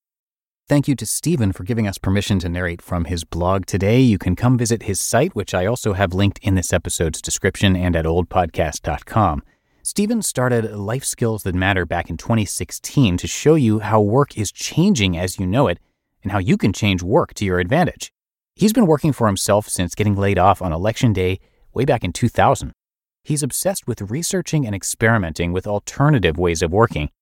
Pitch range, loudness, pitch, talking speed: 90-120 Hz, -19 LUFS, 100 Hz, 195 wpm